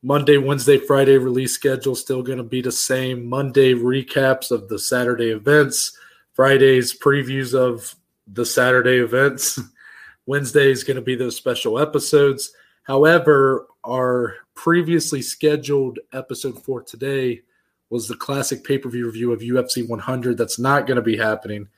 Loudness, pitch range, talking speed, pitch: -19 LUFS, 125-140 Hz, 145 wpm, 130 Hz